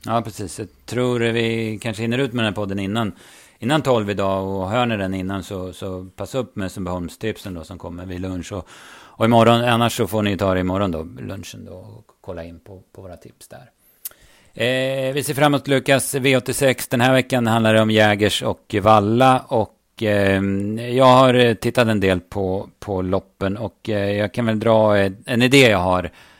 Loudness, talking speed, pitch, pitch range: -19 LUFS, 205 wpm, 110 Hz, 95-120 Hz